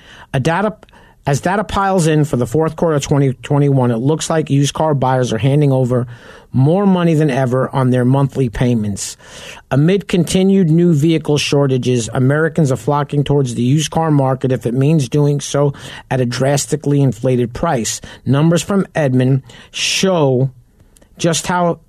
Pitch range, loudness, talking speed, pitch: 130-160 Hz, -15 LUFS, 160 wpm, 140 Hz